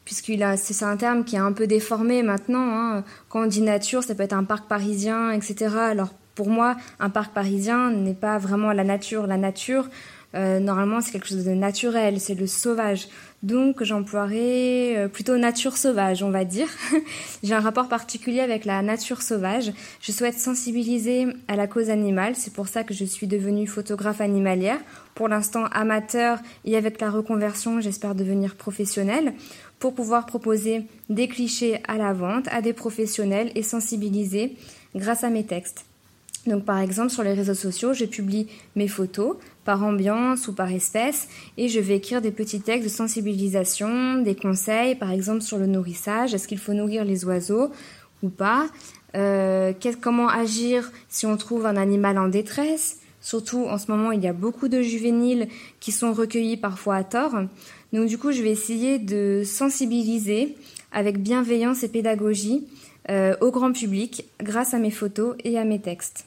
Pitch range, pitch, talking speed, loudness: 200-235 Hz, 215 Hz, 175 wpm, -24 LUFS